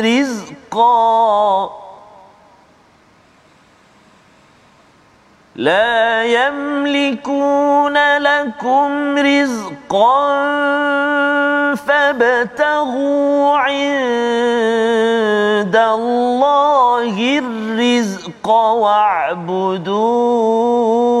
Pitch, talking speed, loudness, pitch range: 245 Hz, 30 wpm, -14 LUFS, 225-285 Hz